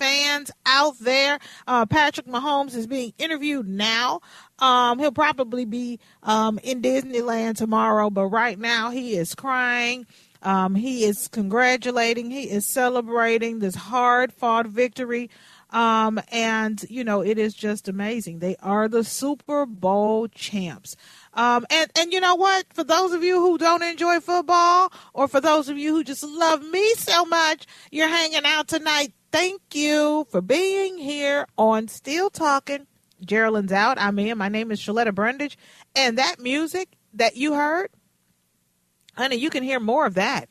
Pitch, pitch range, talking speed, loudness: 250 Hz, 220-300 Hz, 160 wpm, -22 LUFS